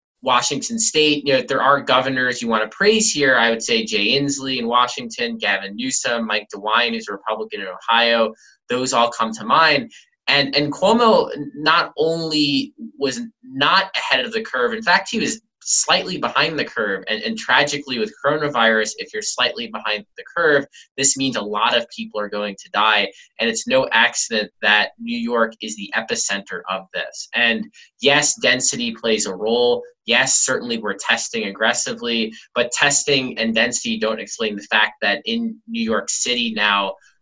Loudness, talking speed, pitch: -18 LUFS, 175 wpm, 135 Hz